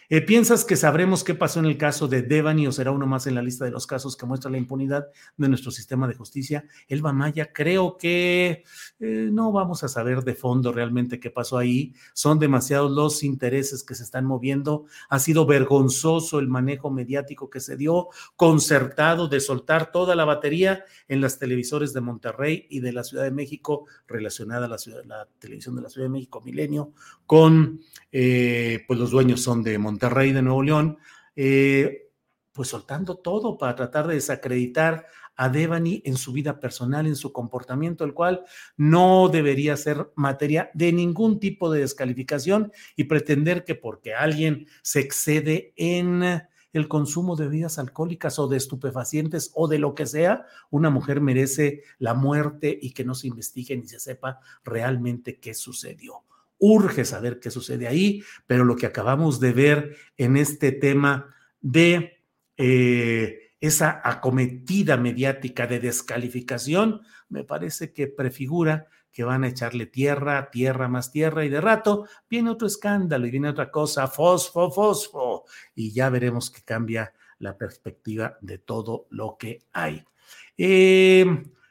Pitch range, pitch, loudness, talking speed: 130-160 Hz, 140 Hz, -23 LUFS, 165 wpm